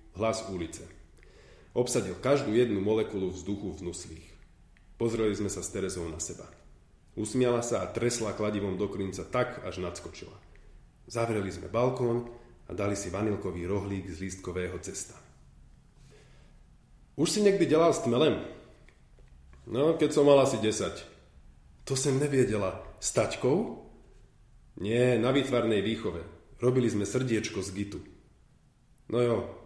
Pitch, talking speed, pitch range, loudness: 100 Hz, 130 wpm, 90-120 Hz, -29 LUFS